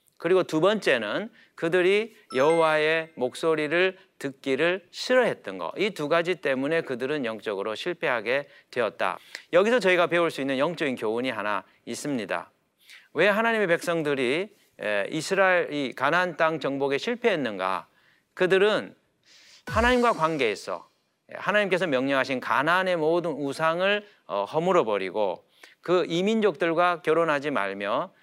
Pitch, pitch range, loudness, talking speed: 175 Hz, 160-195 Hz, -25 LUFS, 305 characters per minute